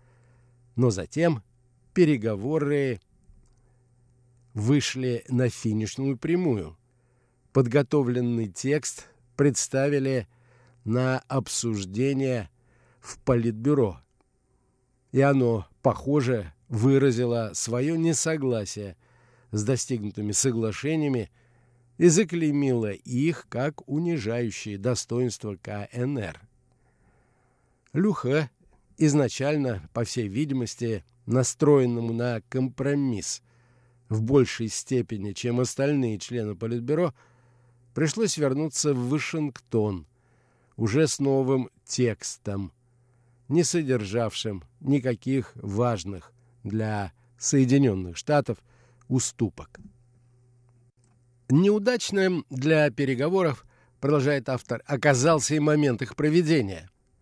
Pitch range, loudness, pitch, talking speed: 115-140 Hz, -26 LUFS, 125 Hz, 75 wpm